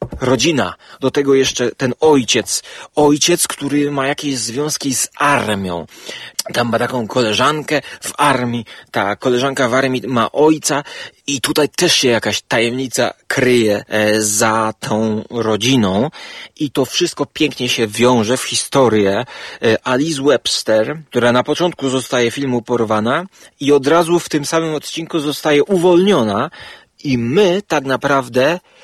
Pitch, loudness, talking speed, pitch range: 135 Hz, -15 LUFS, 135 wpm, 120-150 Hz